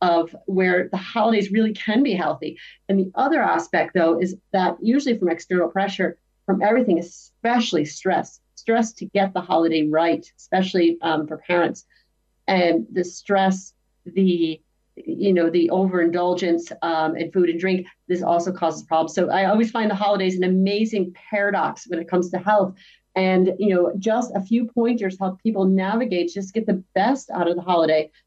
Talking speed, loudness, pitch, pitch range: 175 wpm, -21 LUFS, 185 Hz, 170-200 Hz